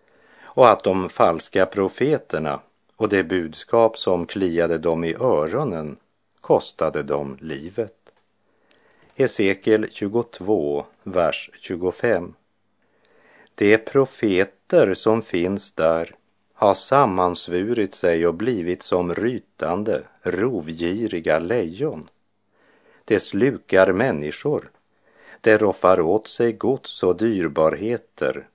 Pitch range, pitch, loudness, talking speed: 85-110 Hz, 90 Hz, -21 LUFS, 90 wpm